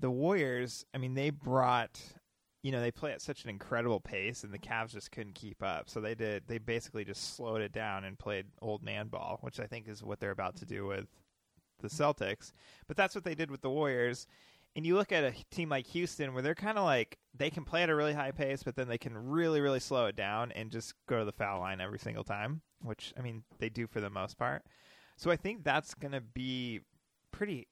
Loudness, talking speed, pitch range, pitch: -36 LUFS, 240 wpm, 110-145 Hz, 125 Hz